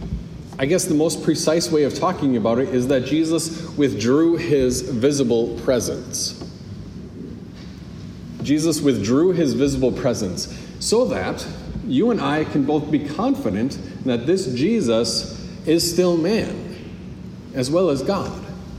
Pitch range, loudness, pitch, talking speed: 130-165 Hz, -20 LUFS, 145 Hz, 130 wpm